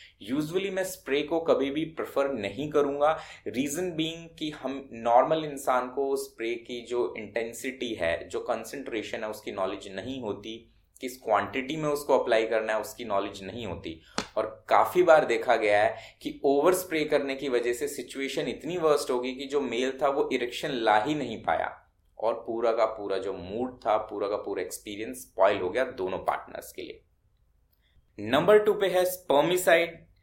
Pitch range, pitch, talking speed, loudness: 115-160 Hz, 140 Hz, 175 wpm, -28 LUFS